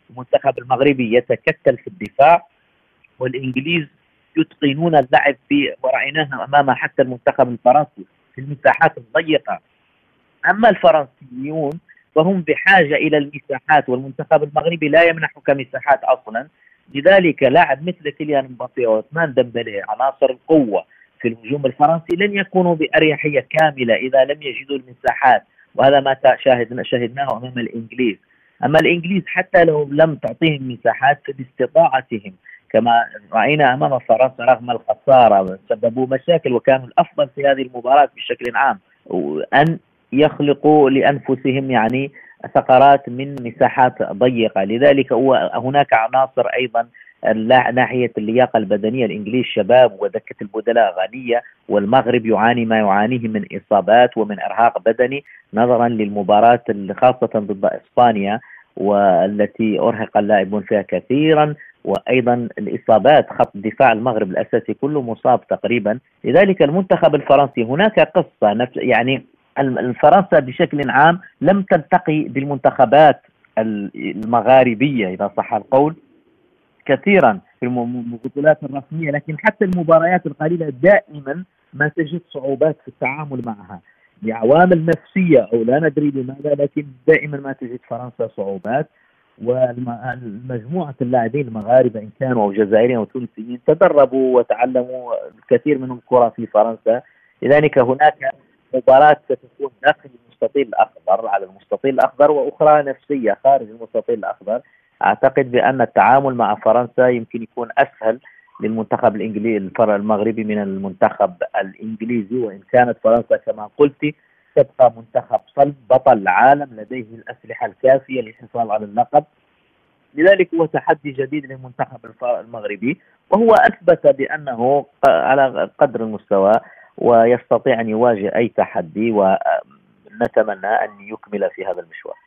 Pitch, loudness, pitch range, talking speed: 130 Hz, -16 LUFS, 120-150 Hz, 115 wpm